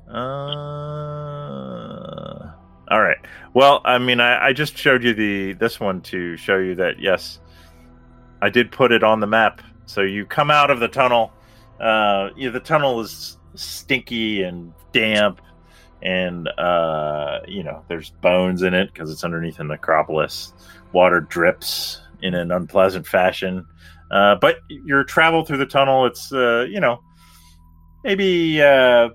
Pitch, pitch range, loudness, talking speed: 100 Hz, 85-125 Hz, -18 LUFS, 150 wpm